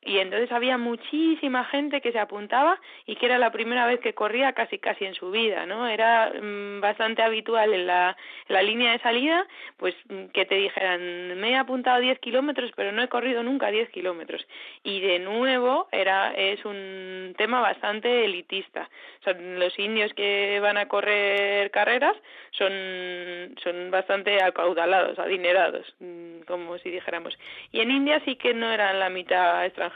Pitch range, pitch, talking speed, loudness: 190-245 Hz, 205 Hz, 170 wpm, -24 LUFS